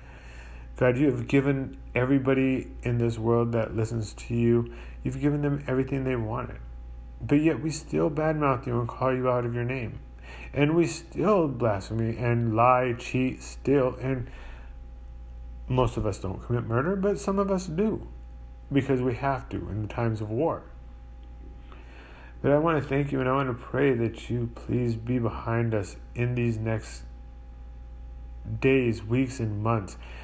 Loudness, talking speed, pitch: -27 LUFS, 165 wpm, 115 Hz